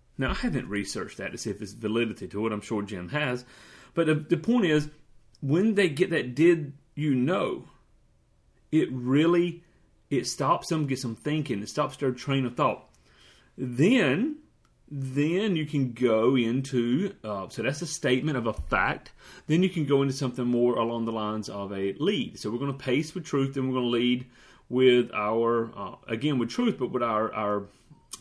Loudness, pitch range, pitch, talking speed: -27 LUFS, 115-150 Hz, 130 Hz, 195 wpm